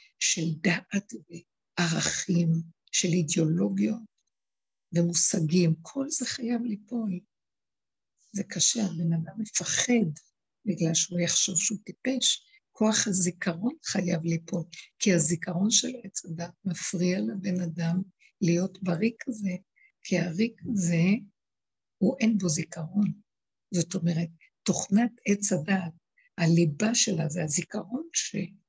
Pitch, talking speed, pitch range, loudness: 185 Hz, 110 wpm, 170-220 Hz, -27 LUFS